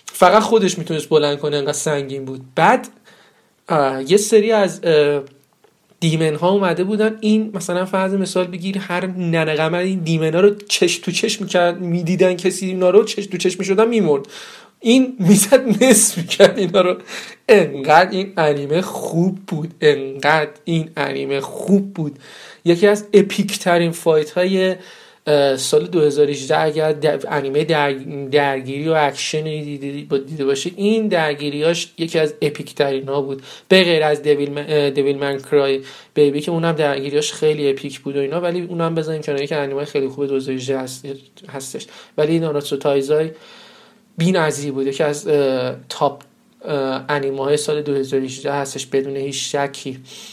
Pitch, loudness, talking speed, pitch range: 155 Hz, -18 LUFS, 155 wpm, 140-185 Hz